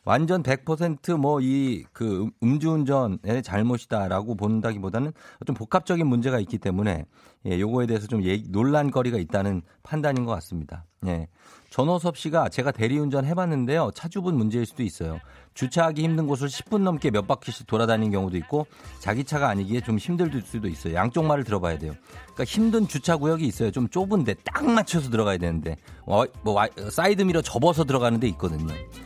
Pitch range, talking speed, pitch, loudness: 100-150 Hz, 380 characters per minute, 120 Hz, -25 LUFS